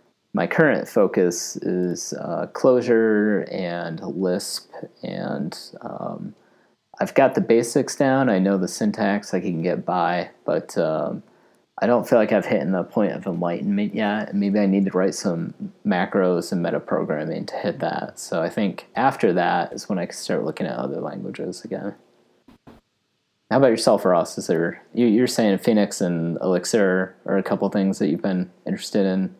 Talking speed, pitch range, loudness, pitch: 175 wpm, 90-125 Hz, -22 LUFS, 100 Hz